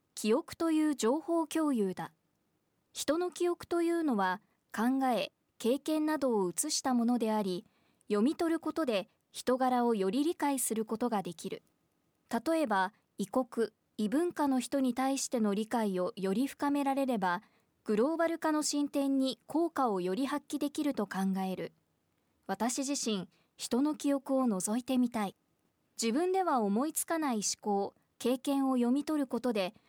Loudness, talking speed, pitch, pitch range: -32 LUFS, 285 characters per minute, 255 Hz, 215-290 Hz